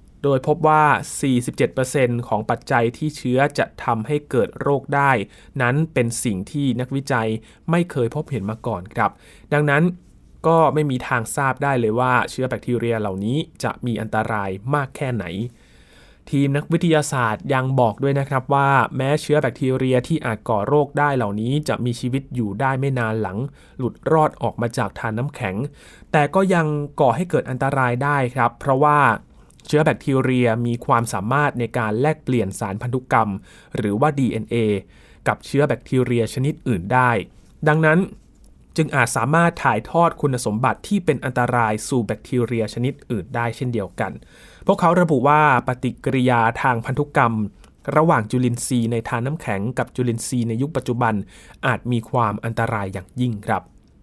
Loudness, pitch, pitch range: -20 LUFS, 125 Hz, 115-145 Hz